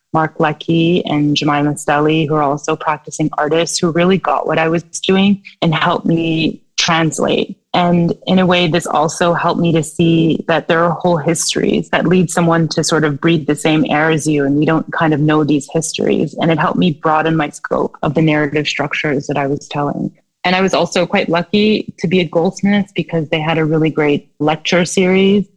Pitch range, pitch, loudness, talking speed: 155-175 Hz, 165 Hz, -15 LUFS, 210 wpm